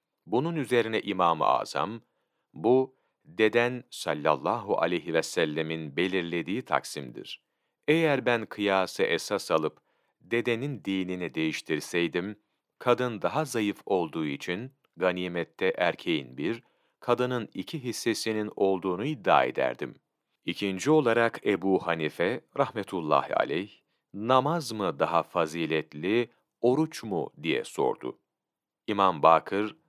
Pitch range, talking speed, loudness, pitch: 90-125 Hz, 100 wpm, -28 LUFS, 110 Hz